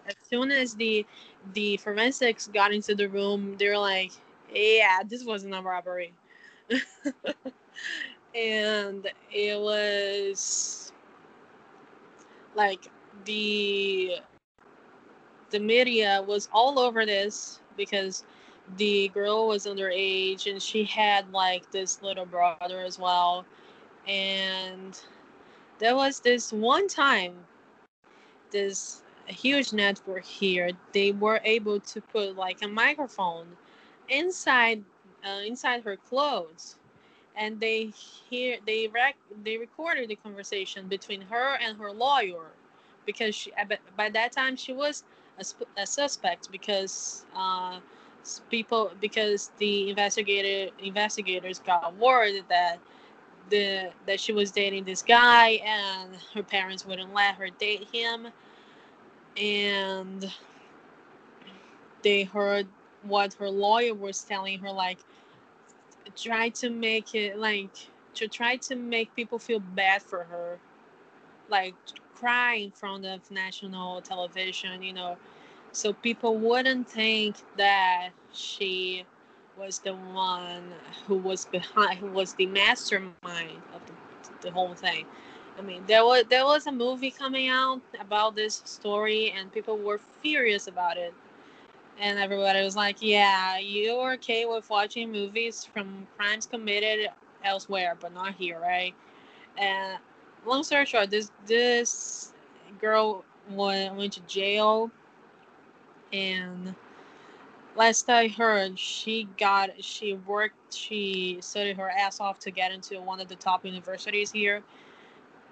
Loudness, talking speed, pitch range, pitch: -27 LUFS, 125 wpm, 195-225 Hz, 205 Hz